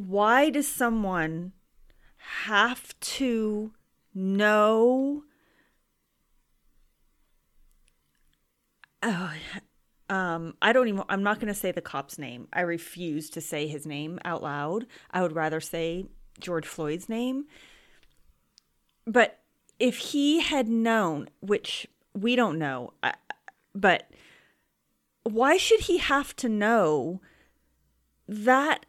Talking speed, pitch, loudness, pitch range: 105 wpm, 185 Hz, -26 LUFS, 150-230 Hz